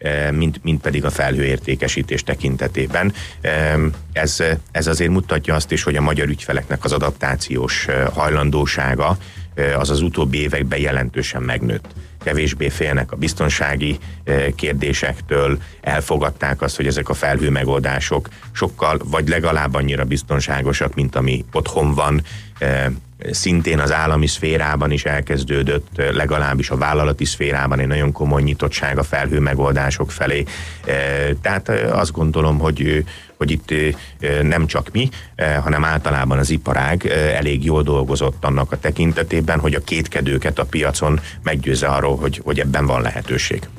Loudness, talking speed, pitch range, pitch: -18 LUFS, 130 wpm, 70-75 Hz, 75 Hz